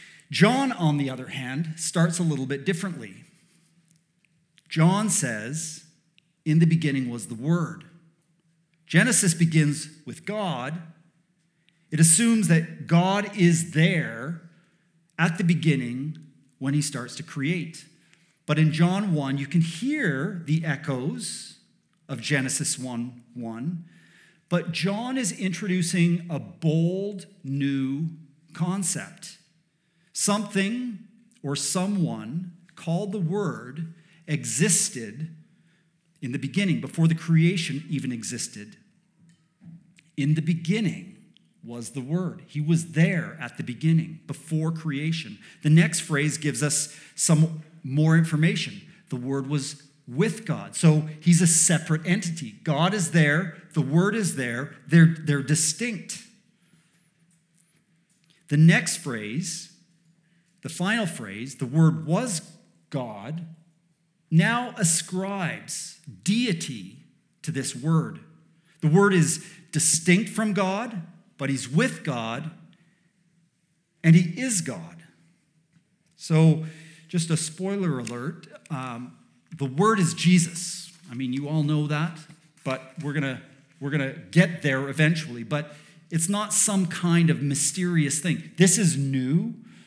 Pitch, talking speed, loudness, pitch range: 165 Hz, 120 wpm, -24 LUFS, 150-175 Hz